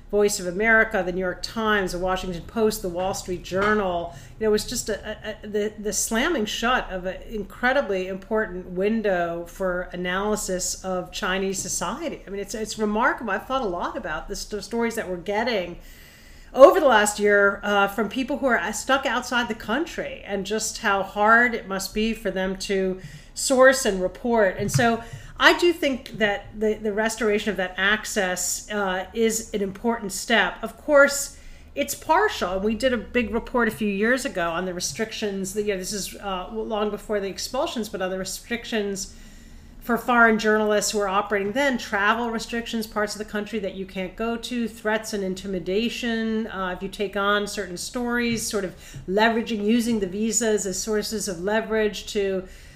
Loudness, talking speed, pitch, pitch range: -23 LUFS, 185 wpm, 210 Hz, 190-225 Hz